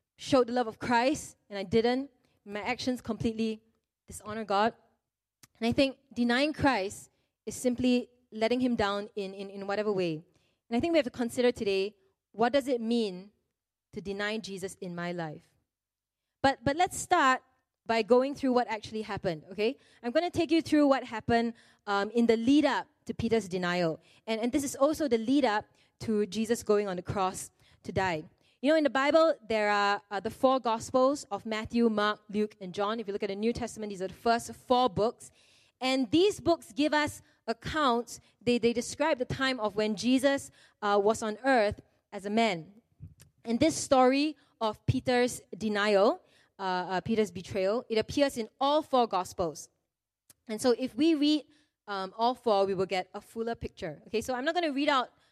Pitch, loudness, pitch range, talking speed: 230 Hz, -29 LUFS, 205-260 Hz, 195 wpm